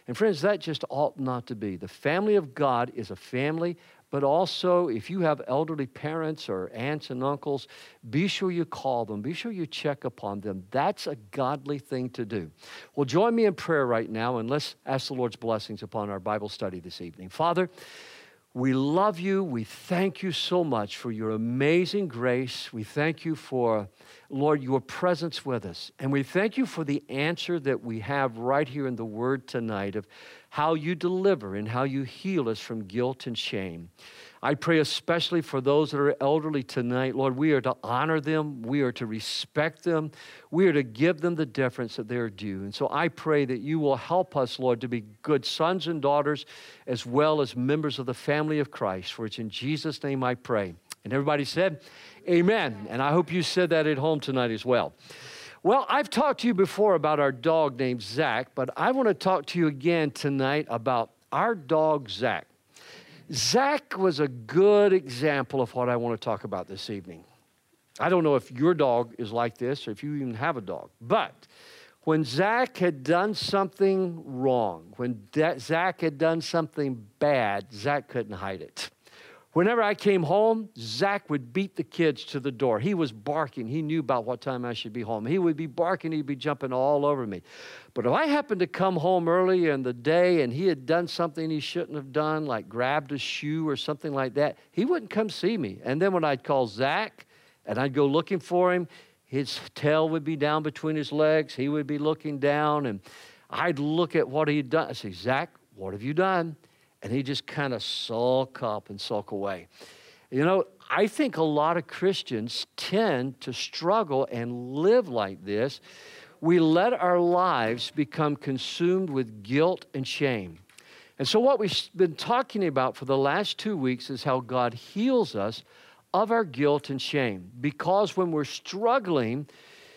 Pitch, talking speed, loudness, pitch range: 145 Hz, 200 wpm, -27 LUFS, 125-170 Hz